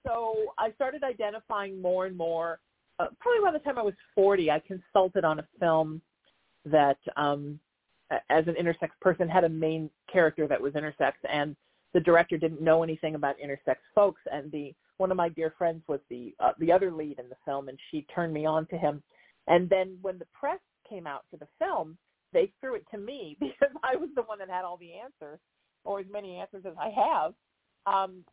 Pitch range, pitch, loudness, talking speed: 155-200 Hz, 175 Hz, -29 LUFS, 210 wpm